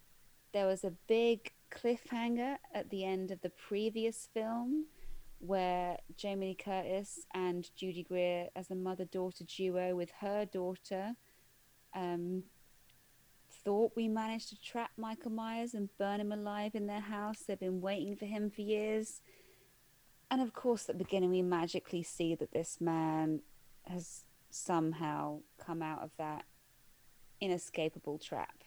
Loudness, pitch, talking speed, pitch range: -38 LUFS, 190 Hz, 140 wpm, 175-215 Hz